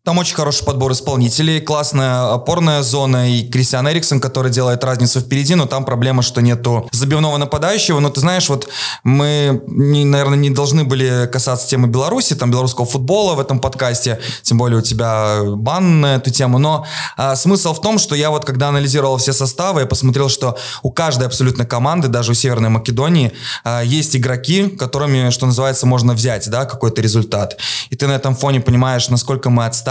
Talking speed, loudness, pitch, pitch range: 185 wpm, -14 LUFS, 135 Hz, 125-145 Hz